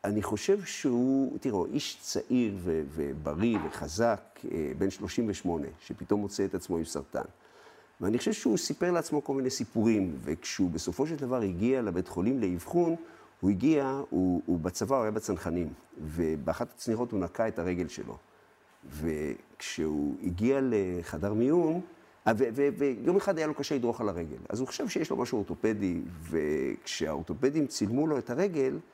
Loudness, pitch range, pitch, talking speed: -31 LUFS, 90-135 Hz, 105 Hz, 145 wpm